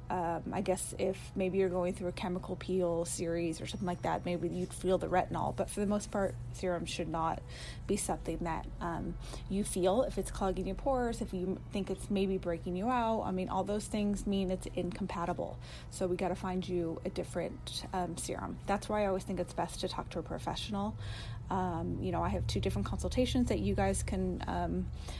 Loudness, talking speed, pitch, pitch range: -35 LUFS, 215 wpm, 180 Hz, 165-190 Hz